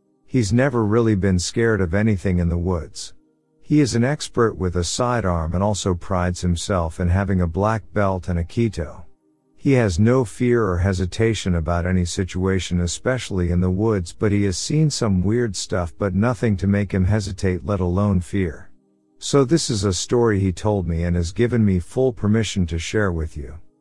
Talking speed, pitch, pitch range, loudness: 190 wpm, 100 Hz, 90-110 Hz, -21 LUFS